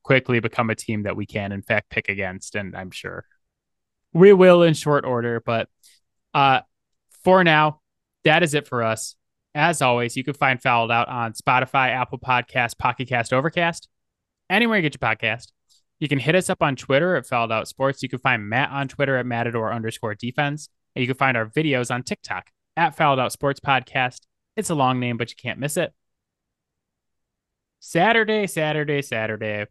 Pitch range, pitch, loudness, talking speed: 115-145 Hz, 125 Hz, -21 LUFS, 185 wpm